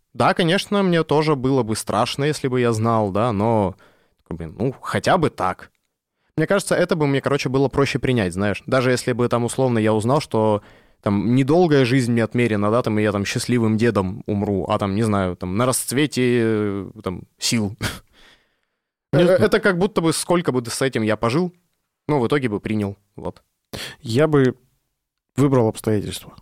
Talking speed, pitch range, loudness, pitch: 175 wpm, 105-140 Hz, -20 LUFS, 120 Hz